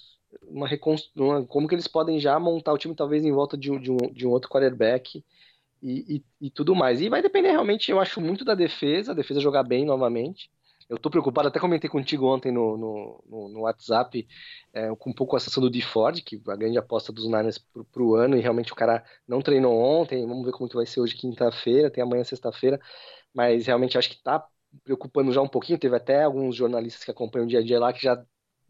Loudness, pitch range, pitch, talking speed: -24 LUFS, 120-145 Hz, 130 Hz, 230 wpm